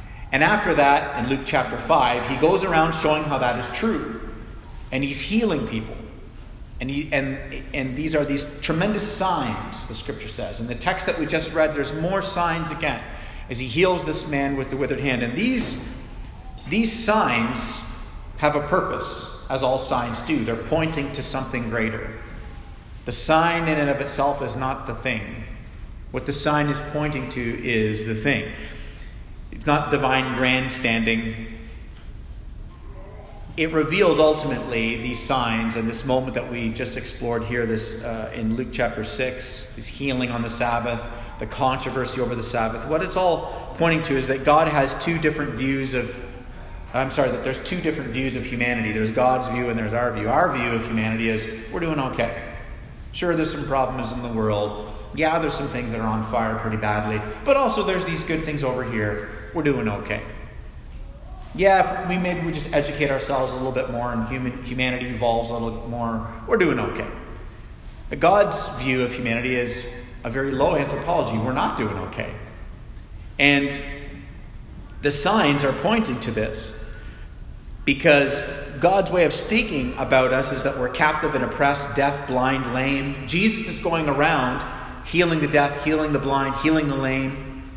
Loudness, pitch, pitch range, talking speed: -23 LUFS, 130 Hz, 115-150 Hz, 175 wpm